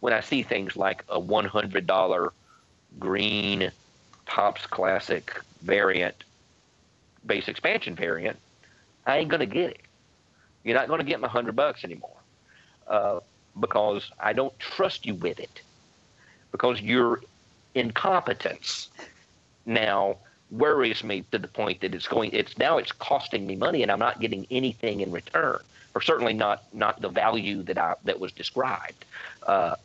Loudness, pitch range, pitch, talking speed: -27 LUFS, 100-125 Hz, 110 Hz, 145 wpm